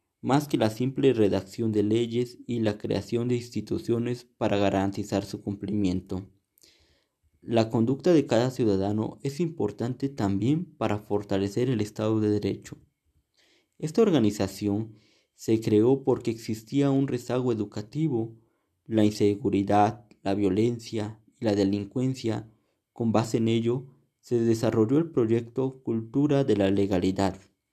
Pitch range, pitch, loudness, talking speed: 100-120 Hz, 110 Hz, -27 LUFS, 125 wpm